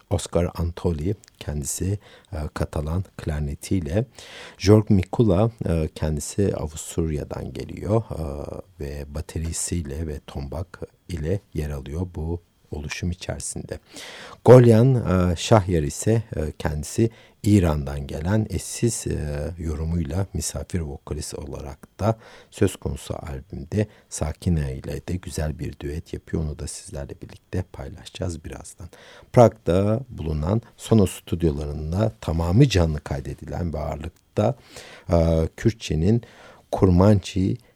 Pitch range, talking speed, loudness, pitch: 75-105 Hz, 105 wpm, -24 LUFS, 85 Hz